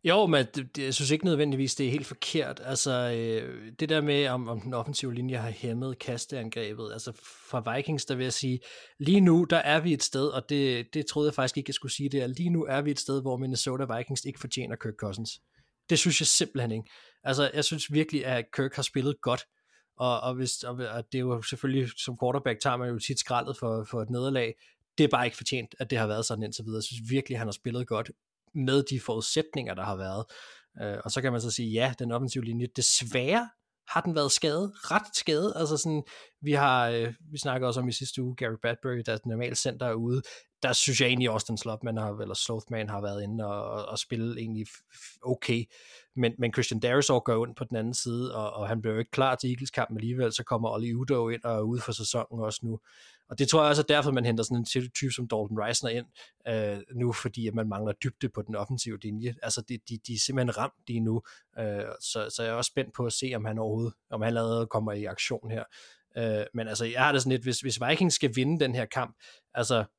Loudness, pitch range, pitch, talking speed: -29 LUFS, 115-135 Hz, 125 Hz, 245 wpm